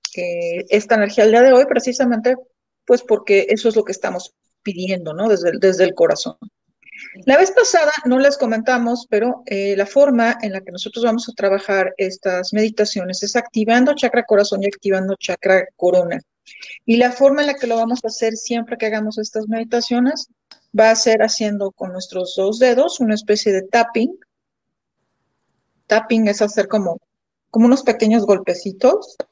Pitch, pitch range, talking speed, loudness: 220 Hz, 195-245 Hz, 170 wpm, -17 LUFS